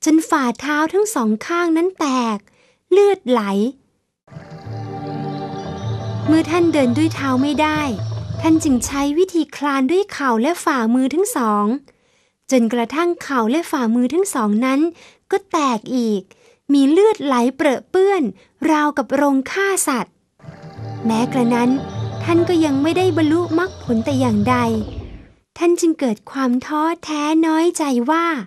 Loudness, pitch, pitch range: -18 LUFS, 280 Hz, 240-330 Hz